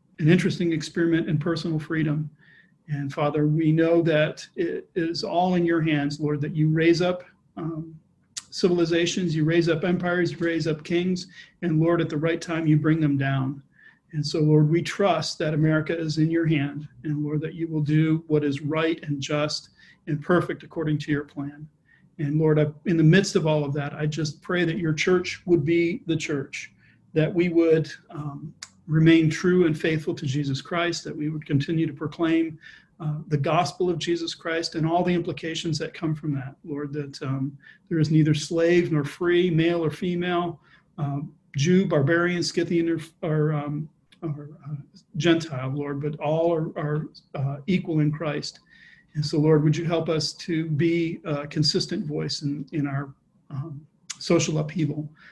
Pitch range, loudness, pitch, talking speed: 150-170 Hz, -24 LUFS, 160 Hz, 185 wpm